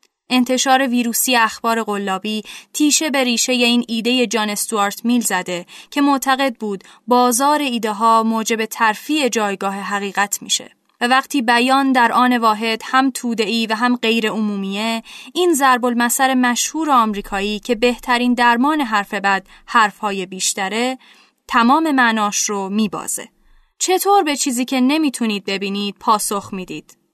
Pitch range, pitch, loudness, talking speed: 210-260 Hz, 235 Hz, -17 LUFS, 135 wpm